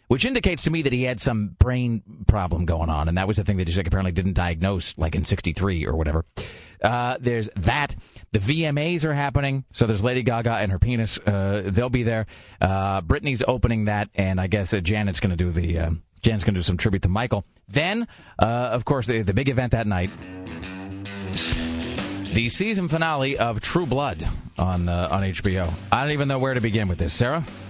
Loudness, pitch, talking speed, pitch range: -23 LUFS, 105 Hz, 210 wpm, 95-125 Hz